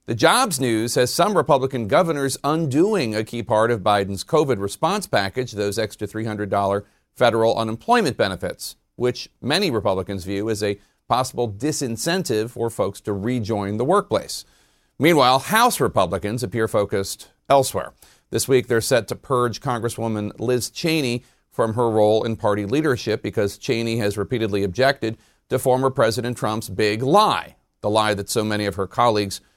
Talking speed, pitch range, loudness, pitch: 155 wpm, 105-130 Hz, -21 LUFS, 115 Hz